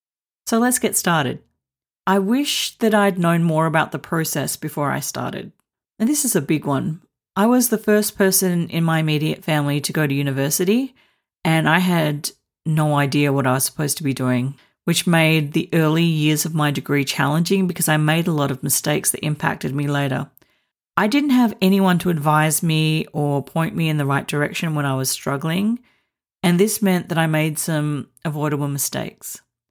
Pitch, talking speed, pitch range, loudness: 160 Hz, 190 wpm, 145-185 Hz, -19 LUFS